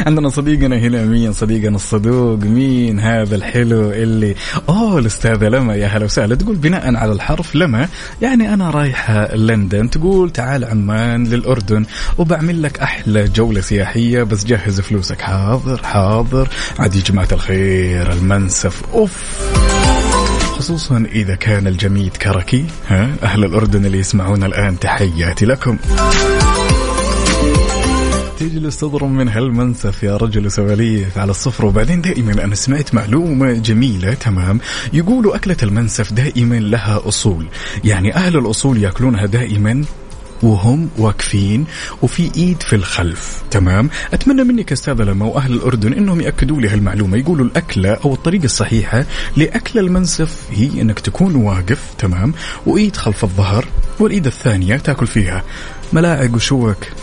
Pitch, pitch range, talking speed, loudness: 115 Hz, 105-140 Hz, 130 wpm, -15 LUFS